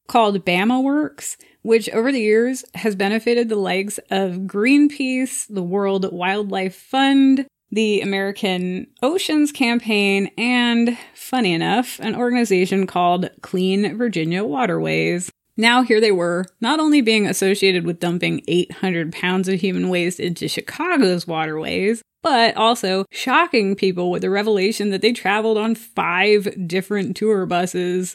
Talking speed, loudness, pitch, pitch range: 135 wpm, -19 LUFS, 200 Hz, 185-235 Hz